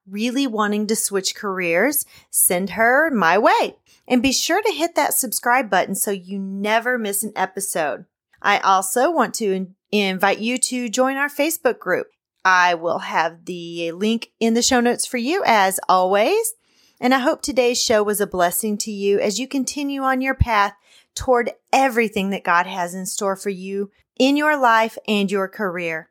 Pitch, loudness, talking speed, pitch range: 215 Hz, -19 LUFS, 180 wpm, 195-255 Hz